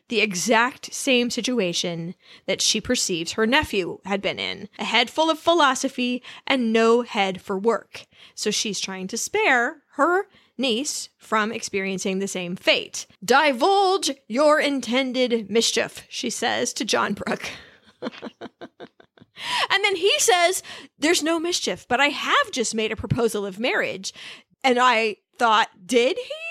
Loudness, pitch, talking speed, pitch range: -22 LUFS, 240 Hz, 145 wpm, 210-285 Hz